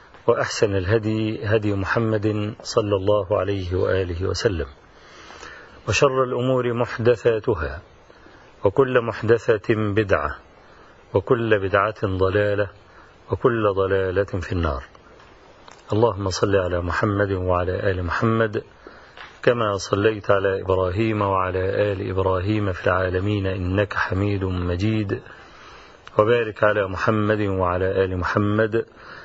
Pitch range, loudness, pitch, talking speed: 95-110 Hz, -22 LUFS, 105 Hz, 95 wpm